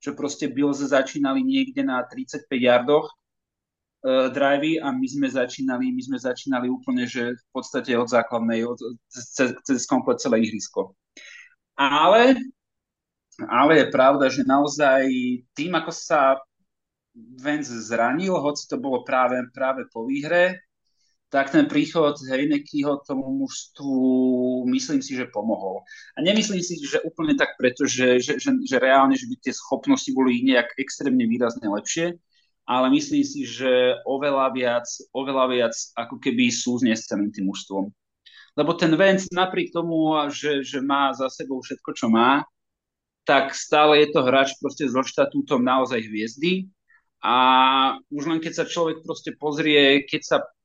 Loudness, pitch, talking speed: -22 LUFS, 145 Hz, 145 wpm